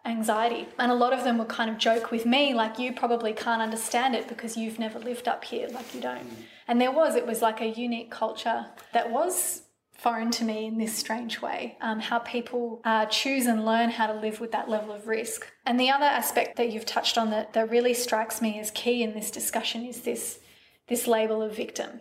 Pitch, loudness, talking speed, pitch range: 230 Hz, -27 LUFS, 230 wpm, 220-240 Hz